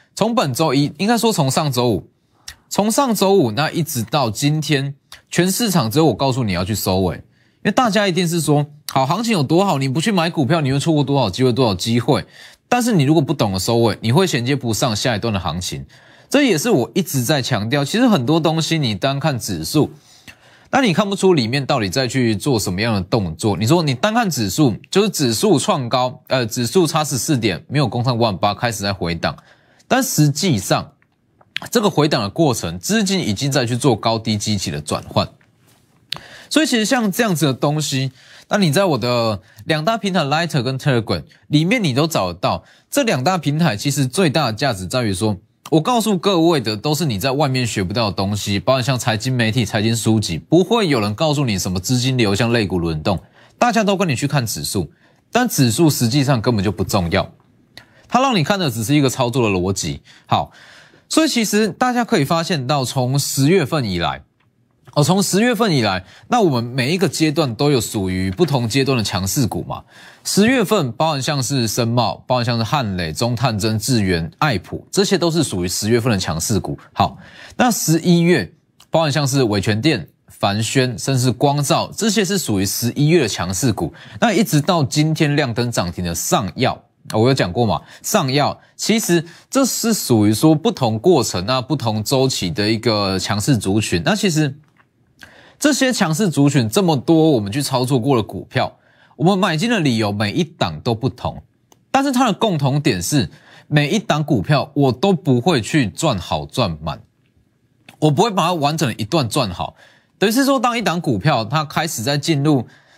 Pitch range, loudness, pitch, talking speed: 115-165 Hz, -18 LUFS, 140 Hz, 295 characters per minute